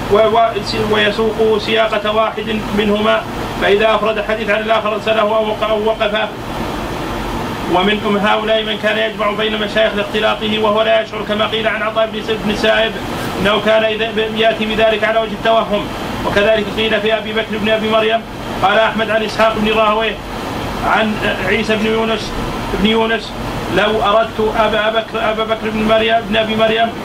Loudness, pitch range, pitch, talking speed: -15 LUFS, 215-220 Hz, 220 Hz, 150 wpm